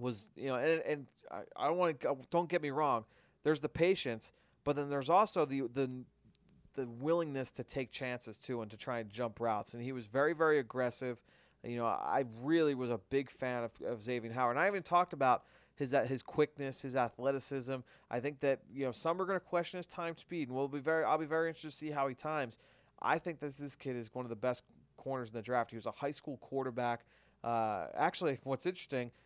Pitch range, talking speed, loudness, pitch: 125-155 Hz, 230 wpm, -37 LUFS, 135 Hz